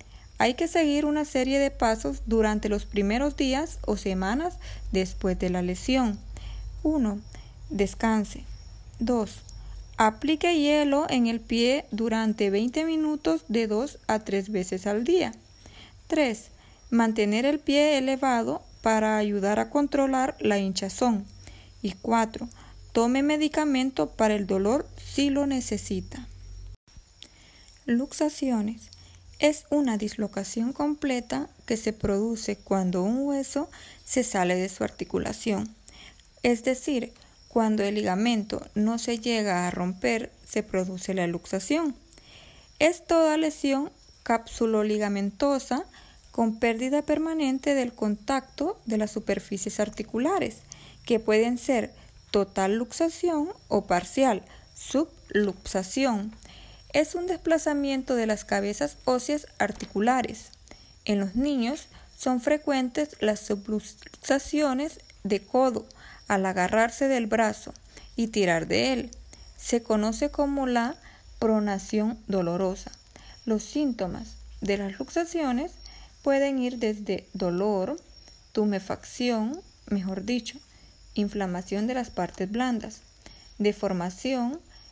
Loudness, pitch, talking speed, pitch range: -27 LUFS, 230 Hz, 110 wpm, 200-275 Hz